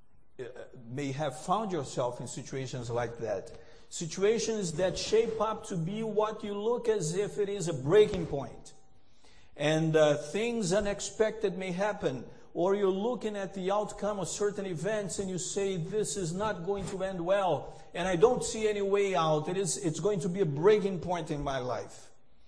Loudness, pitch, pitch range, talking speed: -31 LUFS, 190 Hz, 155-205 Hz, 185 wpm